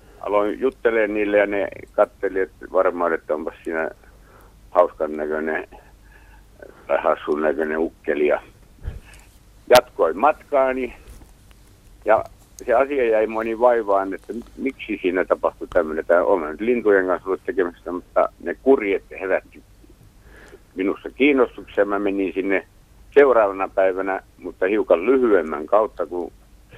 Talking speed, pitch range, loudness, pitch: 120 wpm, 95-110 Hz, -21 LUFS, 100 Hz